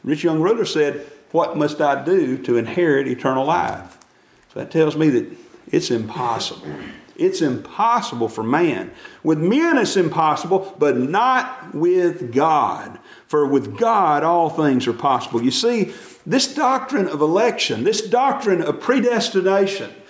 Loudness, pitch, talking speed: -19 LUFS, 195 Hz, 145 wpm